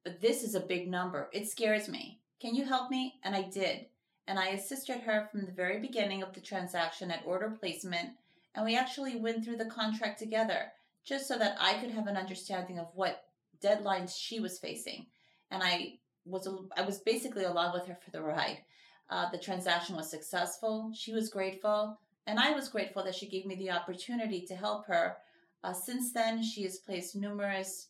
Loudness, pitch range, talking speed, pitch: -35 LUFS, 185-225 Hz, 200 wpm, 195 Hz